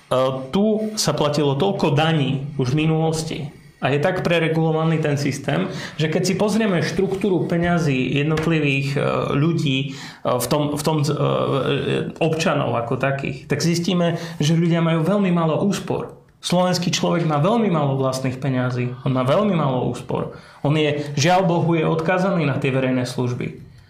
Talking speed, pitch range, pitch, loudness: 150 wpm, 140-175 Hz, 155 Hz, -20 LUFS